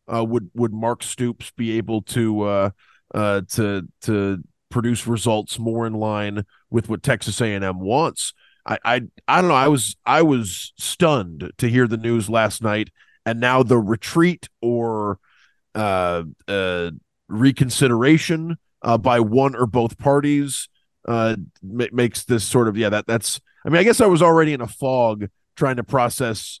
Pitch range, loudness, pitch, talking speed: 105-130 Hz, -20 LUFS, 115 Hz, 170 wpm